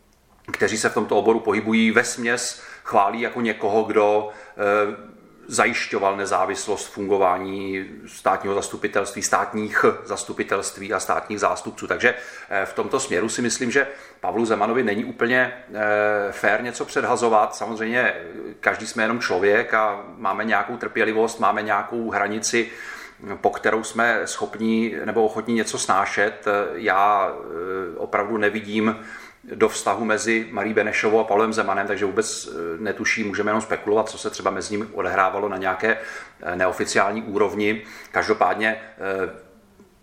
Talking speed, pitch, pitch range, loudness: 125 wpm, 110 Hz, 105-115 Hz, -22 LUFS